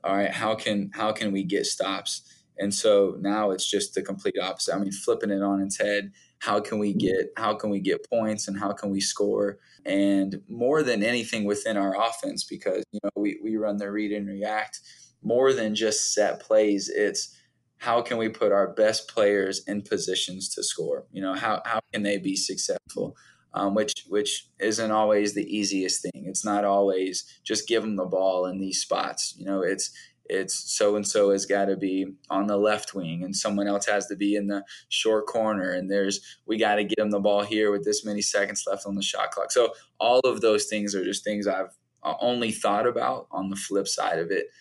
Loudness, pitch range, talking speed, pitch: -26 LUFS, 100-110 Hz, 215 wpm, 100 Hz